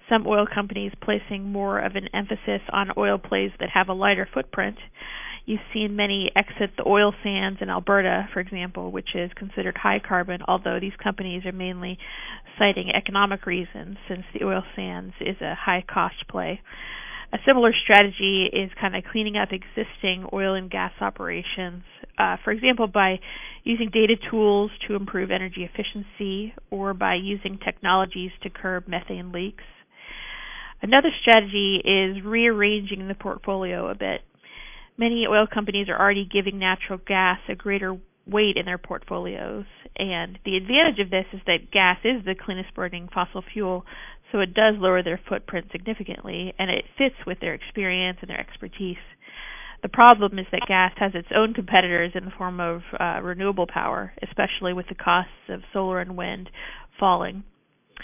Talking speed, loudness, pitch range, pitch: 165 wpm, -23 LUFS, 185-210 Hz, 195 Hz